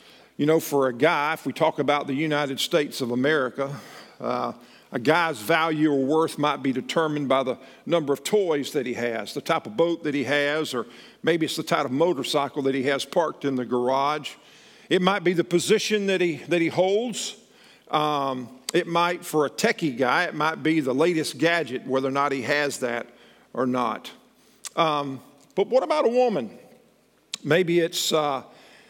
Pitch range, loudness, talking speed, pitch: 135-170 Hz, -24 LUFS, 190 wpm, 155 Hz